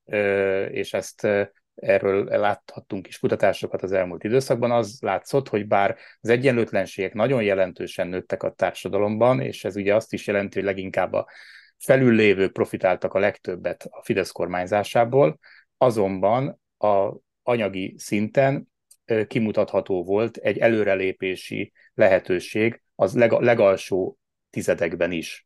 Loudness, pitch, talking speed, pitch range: -23 LUFS, 105 Hz, 120 wpm, 95-115 Hz